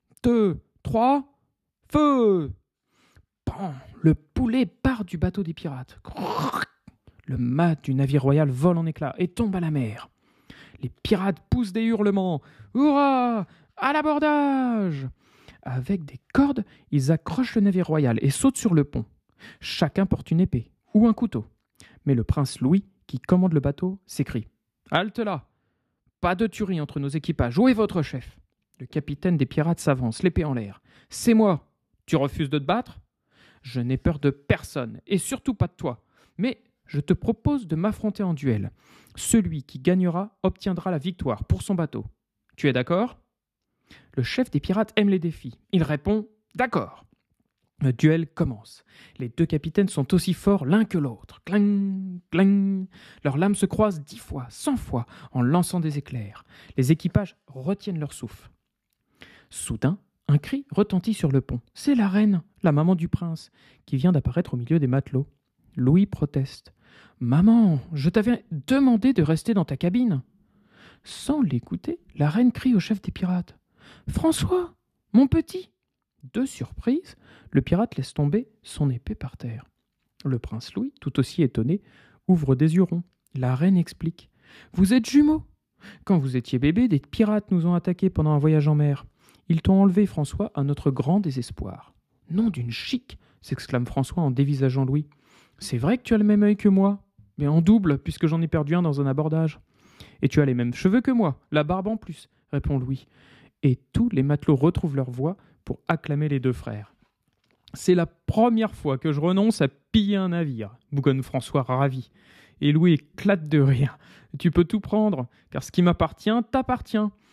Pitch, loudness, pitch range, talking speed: 165 Hz, -24 LUFS, 135-205 Hz, 170 wpm